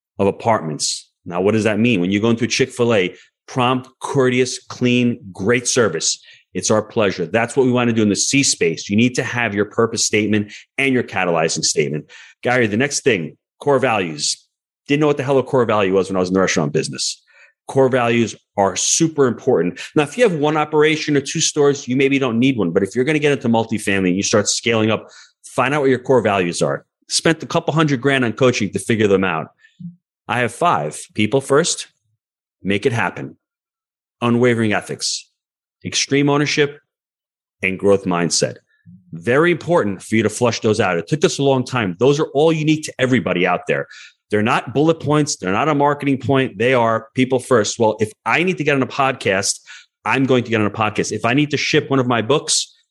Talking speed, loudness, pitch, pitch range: 215 wpm, -17 LUFS, 125 Hz, 105-140 Hz